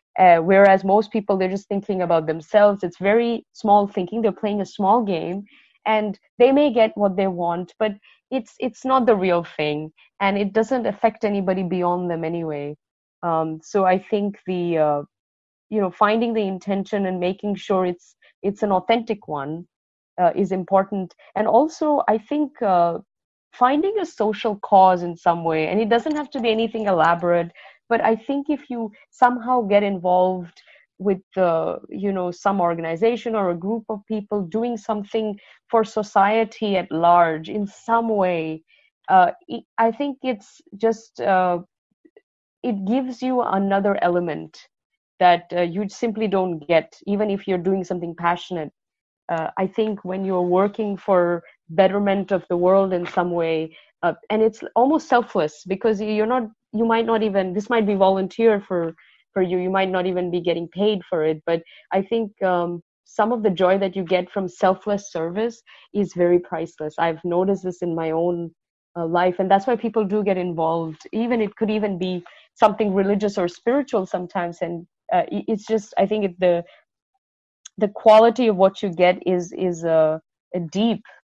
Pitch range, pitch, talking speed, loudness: 175-220 Hz, 195 Hz, 175 wpm, -21 LUFS